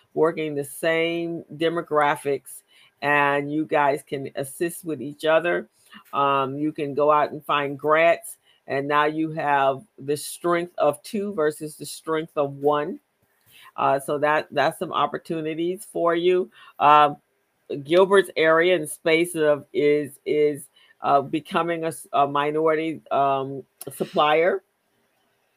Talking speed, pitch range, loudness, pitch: 130 wpm, 145-165 Hz, -23 LUFS, 150 Hz